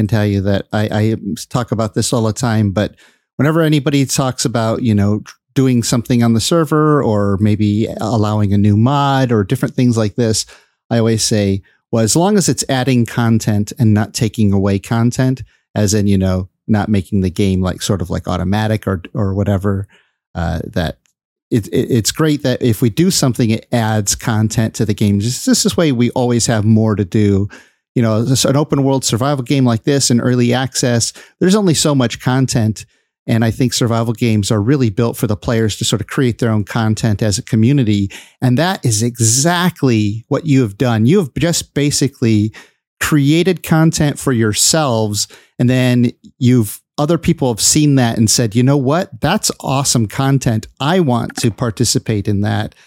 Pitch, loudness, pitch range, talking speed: 120 Hz, -15 LUFS, 110-135 Hz, 190 wpm